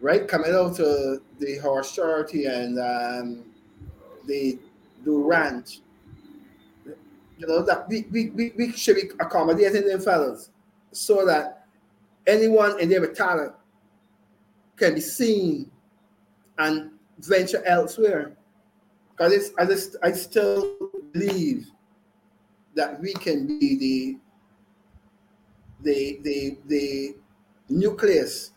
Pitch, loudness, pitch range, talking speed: 185 Hz, -23 LUFS, 140-220 Hz, 105 wpm